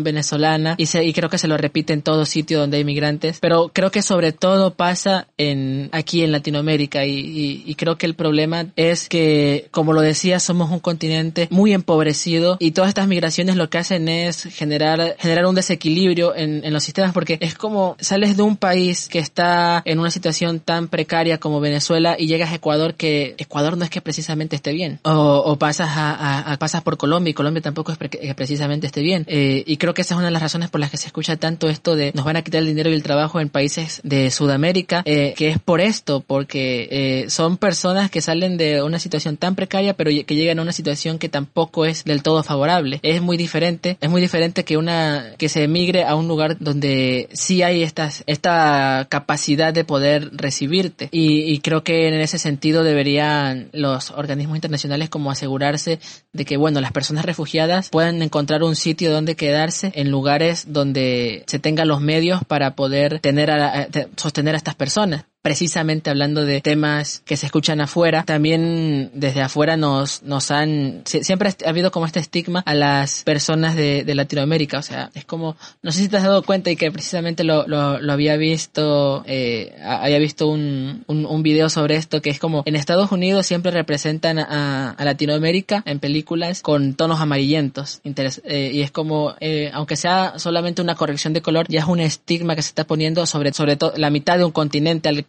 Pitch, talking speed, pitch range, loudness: 155 Hz, 205 wpm, 145-170 Hz, -19 LUFS